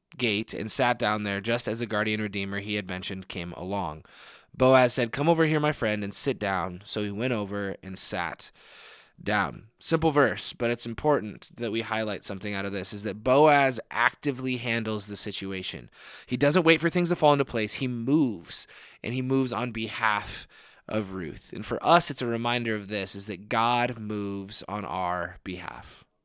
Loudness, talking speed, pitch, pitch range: -27 LUFS, 190 wpm, 110 Hz, 100-125 Hz